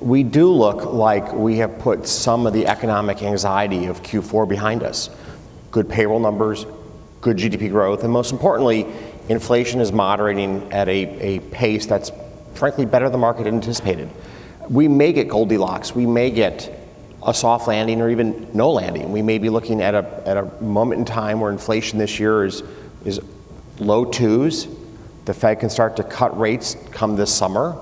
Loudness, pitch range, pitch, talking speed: -19 LUFS, 105-115 Hz, 110 Hz, 175 wpm